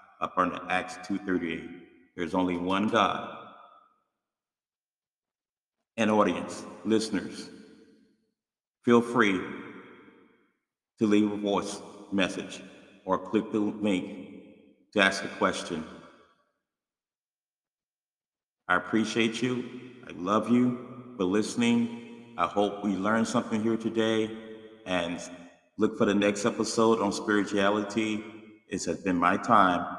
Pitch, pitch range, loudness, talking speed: 110 Hz, 100-115 Hz, -28 LUFS, 110 wpm